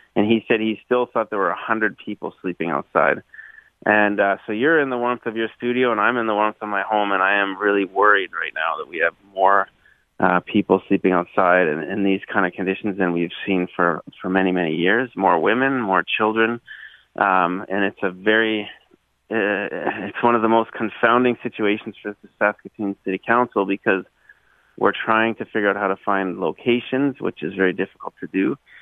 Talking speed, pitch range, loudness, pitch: 215 wpm, 95-115 Hz, -20 LUFS, 105 Hz